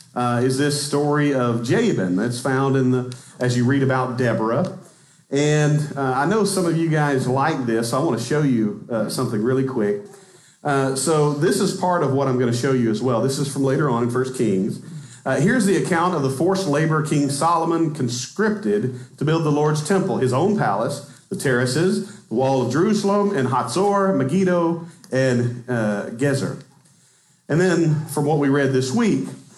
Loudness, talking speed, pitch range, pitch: -20 LUFS, 195 wpm, 130-165 Hz, 145 Hz